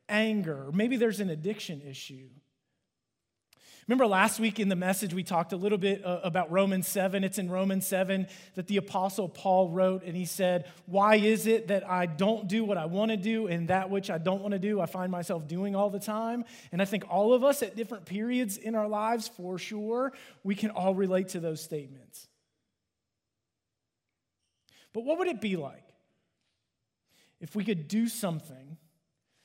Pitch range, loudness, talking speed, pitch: 165-210 Hz, -30 LUFS, 185 wpm, 190 Hz